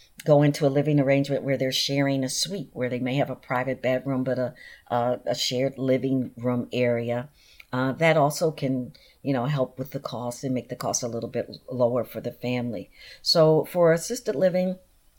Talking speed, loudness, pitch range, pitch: 200 wpm, -25 LUFS, 125-145 Hz, 130 Hz